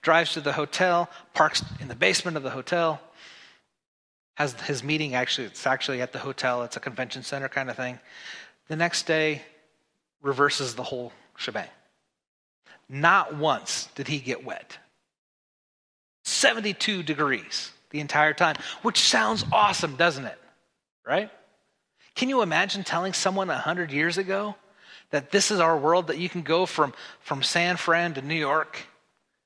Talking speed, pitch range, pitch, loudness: 155 wpm, 140-175 Hz, 155 Hz, -25 LUFS